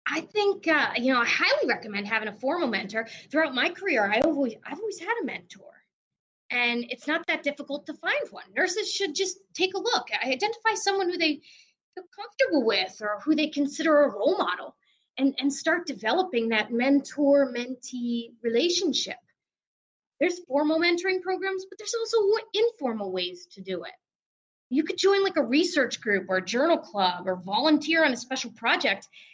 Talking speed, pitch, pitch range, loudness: 175 wpm, 290 Hz, 240-370 Hz, -26 LUFS